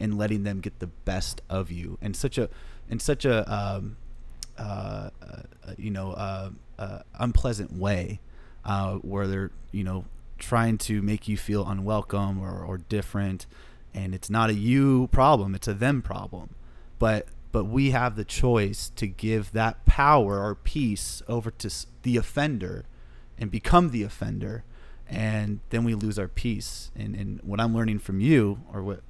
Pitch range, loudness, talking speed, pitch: 95-115 Hz, -27 LUFS, 170 wpm, 105 Hz